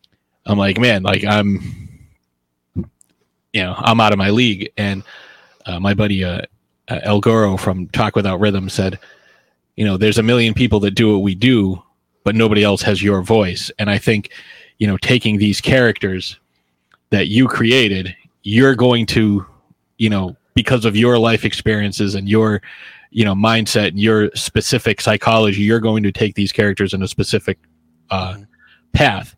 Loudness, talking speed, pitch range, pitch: -15 LUFS, 170 wpm, 95-110 Hz, 105 Hz